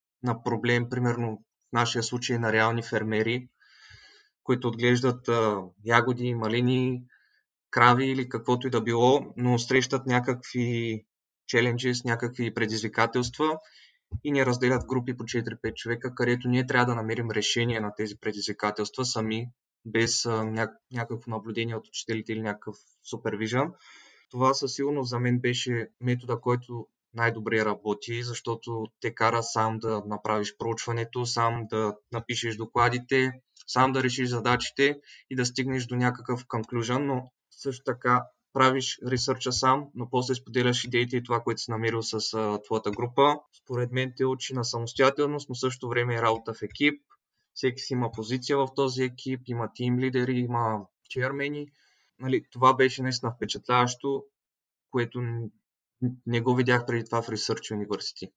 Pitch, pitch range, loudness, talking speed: 120 Hz, 115-130 Hz, -27 LUFS, 145 wpm